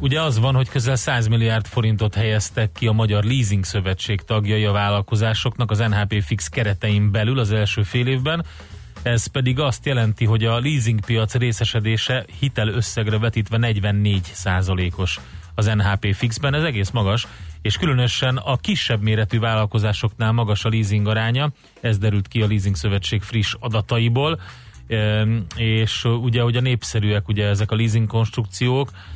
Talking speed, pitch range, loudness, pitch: 150 wpm, 105-120 Hz, -20 LUFS, 110 Hz